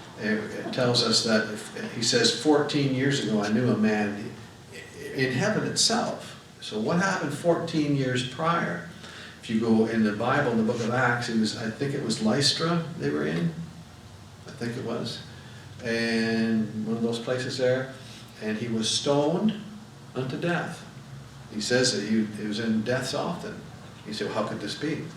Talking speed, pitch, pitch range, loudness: 180 wpm, 120 Hz, 110-145 Hz, -26 LUFS